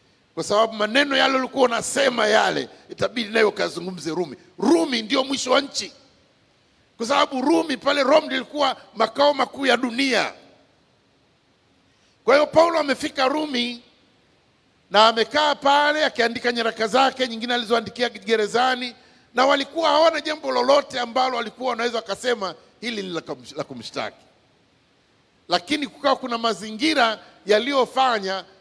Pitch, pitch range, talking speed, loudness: 250 Hz, 225-275 Hz, 115 wpm, -21 LUFS